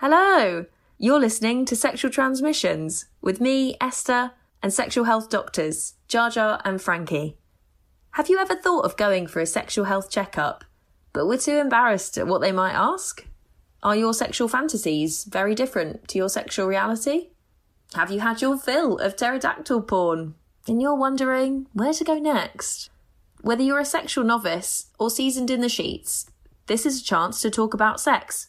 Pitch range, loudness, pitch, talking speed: 195-270 Hz, -23 LUFS, 235 Hz, 170 wpm